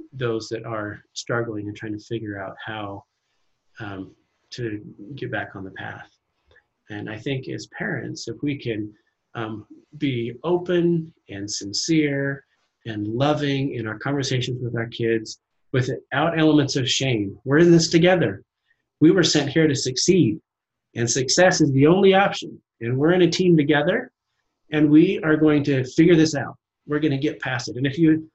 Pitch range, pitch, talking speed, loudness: 115-160 Hz, 140 Hz, 170 wpm, -21 LUFS